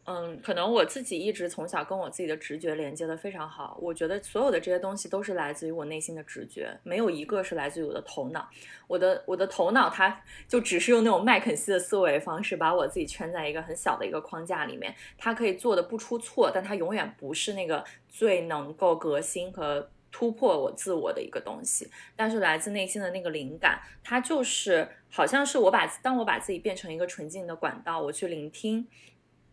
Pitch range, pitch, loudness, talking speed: 165-225 Hz, 185 Hz, -29 LUFS, 330 characters per minute